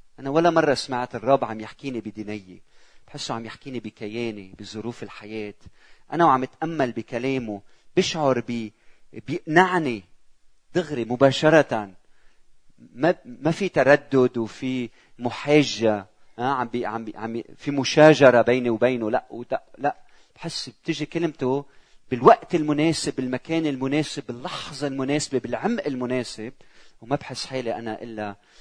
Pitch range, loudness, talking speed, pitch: 115-150 Hz, -23 LUFS, 120 wpm, 130 Hz